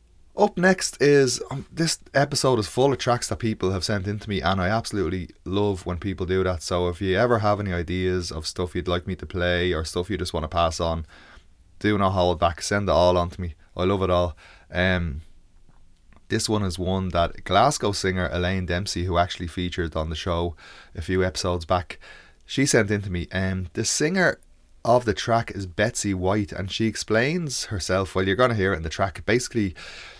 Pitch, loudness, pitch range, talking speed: 95 Hz, -24 LUFS, 90-105 Hz, 215 wpm